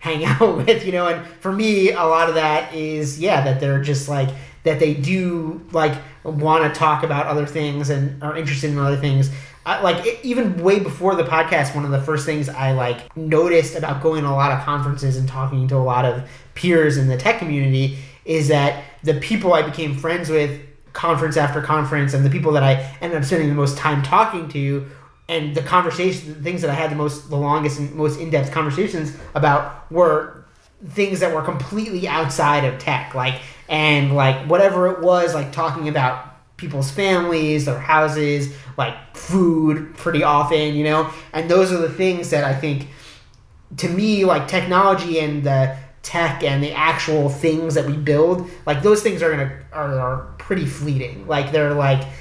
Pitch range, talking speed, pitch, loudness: 140-165 Hz, 195 wpm, 155 Hz, -19 LUFS